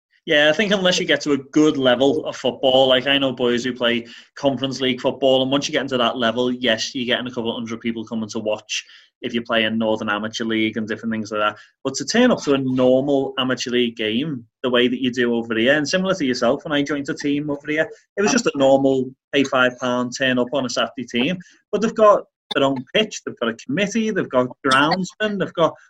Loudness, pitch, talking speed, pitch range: -20 LUFS, 130 Hz, 250 wpm, 120-145 Hz